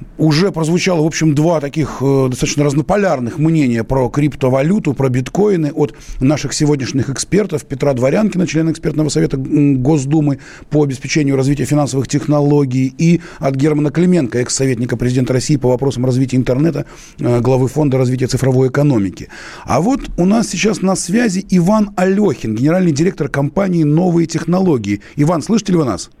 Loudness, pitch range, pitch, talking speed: -15 LUFS, 130-170 Hz, 150 Hz, 145 wpm